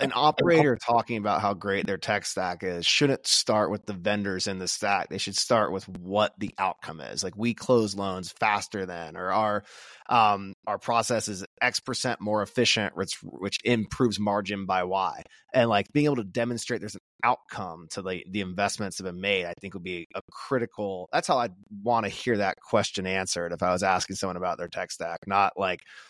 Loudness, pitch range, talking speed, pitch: -27 LUFS, 95-115 Hz, 210 wpm, 100 Hz